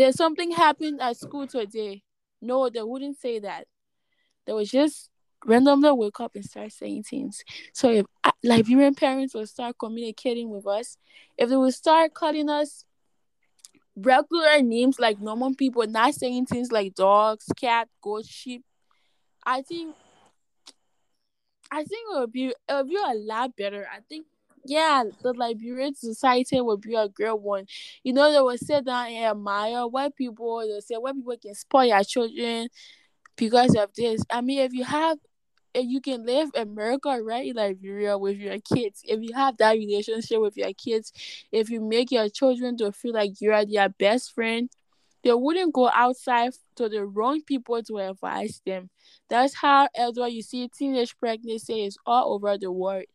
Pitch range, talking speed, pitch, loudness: 220-270 Hz, 175 wpm, 240 Hz, -24 LUFS